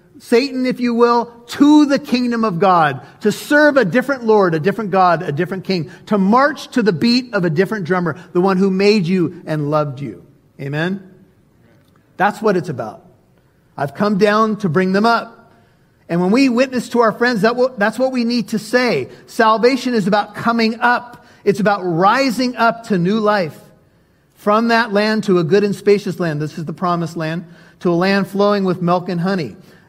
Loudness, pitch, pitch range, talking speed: -16 LUFS, 205 Hz, 175-230 Hz, 195 wpm